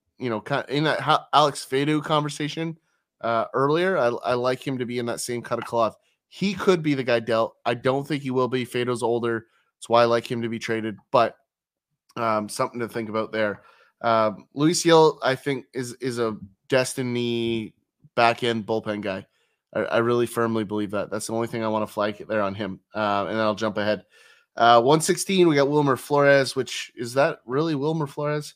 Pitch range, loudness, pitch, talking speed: 110-140 Hz, -24 LUFS, 120 Hz, 205 wpm